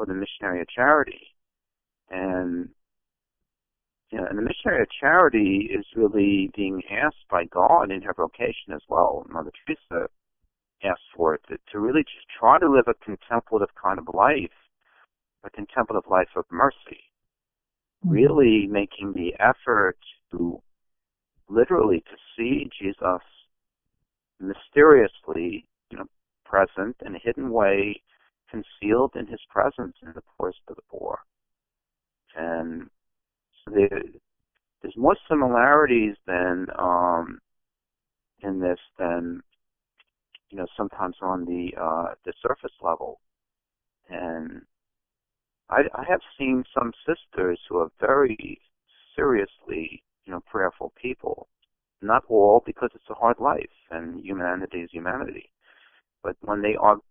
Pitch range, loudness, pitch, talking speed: 90-110 Hz, -23 LUFS, 100 Hz, 125 wpm